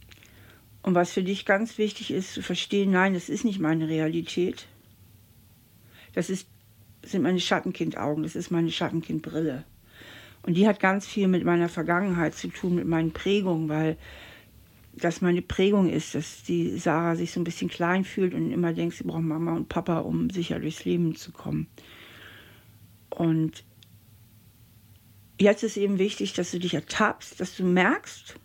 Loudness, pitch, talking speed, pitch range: -27 LUFS, 165 Hz, 160 wpm, 110-180 Hz